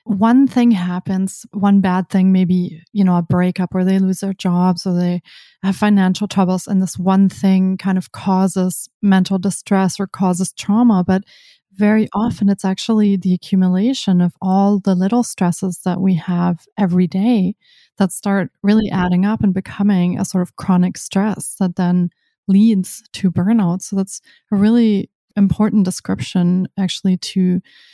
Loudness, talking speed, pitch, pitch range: -16 LUFS, 160 wpm, 190 Hz, 185-205 Hz